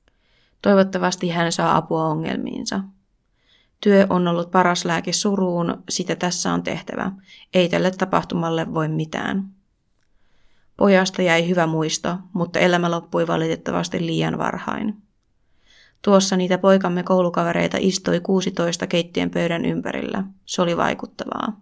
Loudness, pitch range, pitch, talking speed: -21 LUFS, 160-195 Hz, 180 Hz, 115 wpm